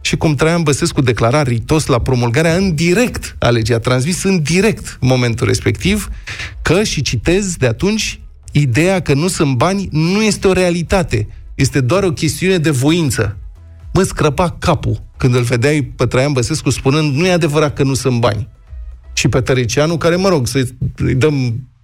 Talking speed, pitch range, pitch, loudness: 170 wpm, 120-170 Hz, 140 Hz, -14 LUFS